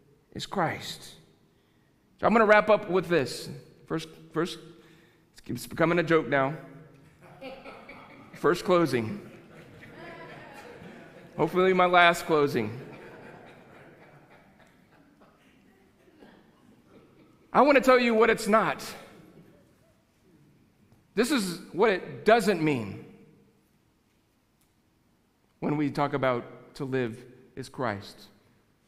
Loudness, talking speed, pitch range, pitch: -25 LUFS, 95 wpm, 120-180 Hz, 155 Hz